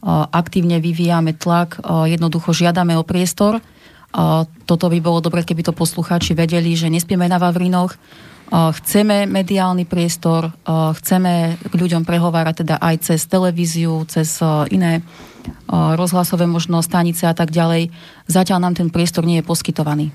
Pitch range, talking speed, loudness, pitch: 165-180 Hz, 135 wpm, -16 LUFS, 170 Hz